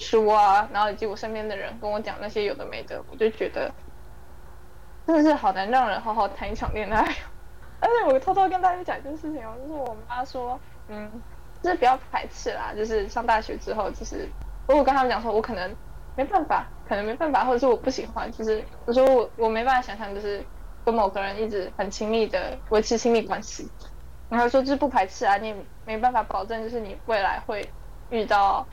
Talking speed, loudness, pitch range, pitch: 320 characters per minute, -25 LUFS, 205-255 Hz, 225 Hz